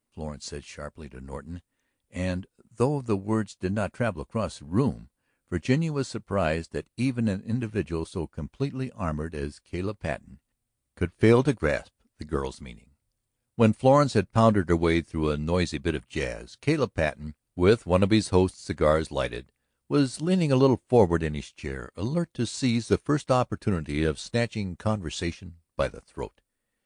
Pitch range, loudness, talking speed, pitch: 80-115 Hz, -27 LUFS, 170 wpm, 95 Hz